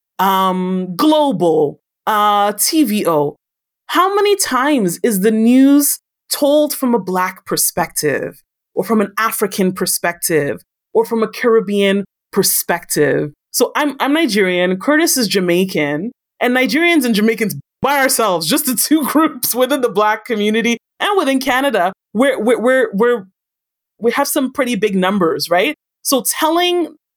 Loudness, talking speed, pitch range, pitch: -15 LUFS, 135 wpm, 195-280 Hz, 230 Hz